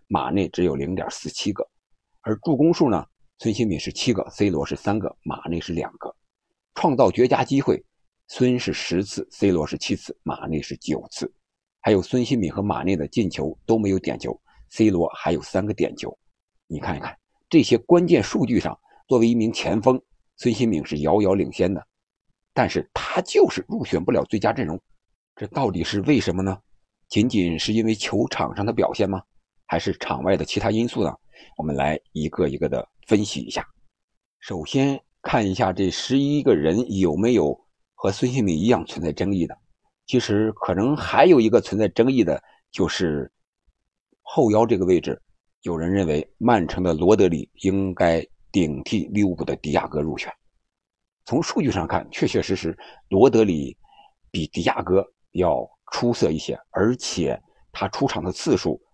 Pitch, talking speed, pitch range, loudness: 105 Hz, 255 characters per minute, 90-125 Hz, -22 LUFS